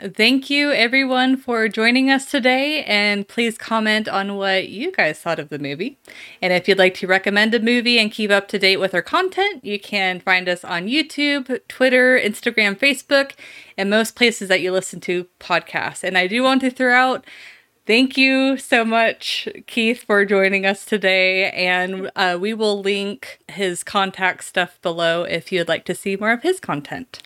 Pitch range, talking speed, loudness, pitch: 185-255 Hz, 185 wpm, -18 LUFS, 210 Hz